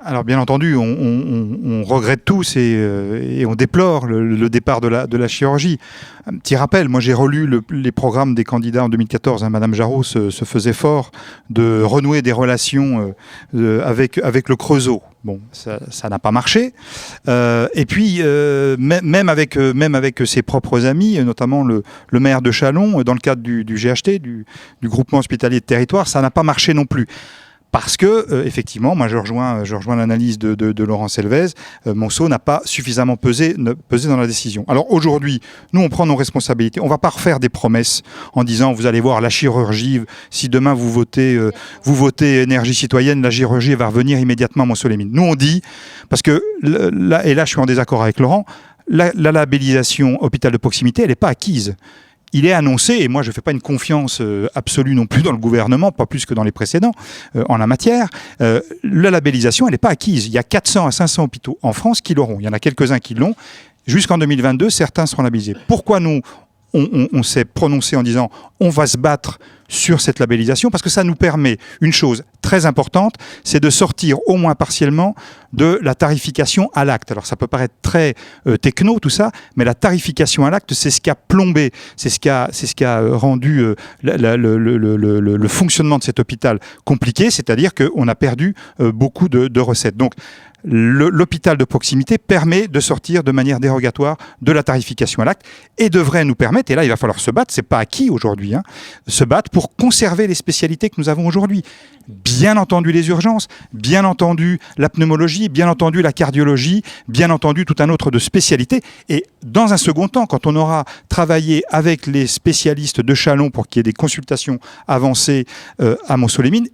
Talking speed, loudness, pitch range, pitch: 210 wpm, -15 LUFS, 120-160 Hz, 135 Hz